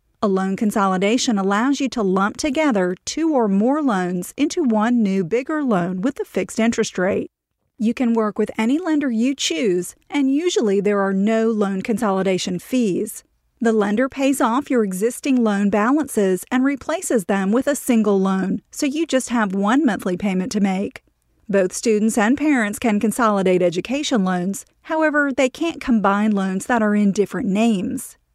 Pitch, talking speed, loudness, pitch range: 225 Hz, 170 wpm, -19 LUFS, 195-265 Hz